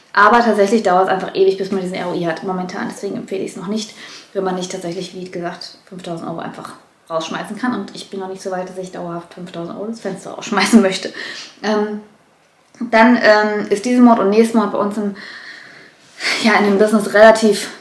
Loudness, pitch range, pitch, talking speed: -16 LUFS, 185-220 Hz, 200 Hz, 210 wpm